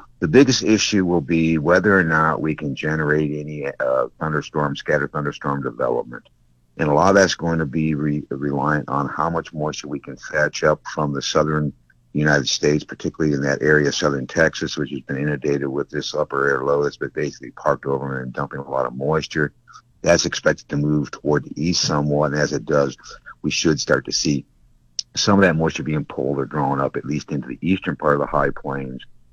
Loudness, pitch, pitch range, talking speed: -20 LUFS, 75 Hz, 70-80 Hz, 210 wpm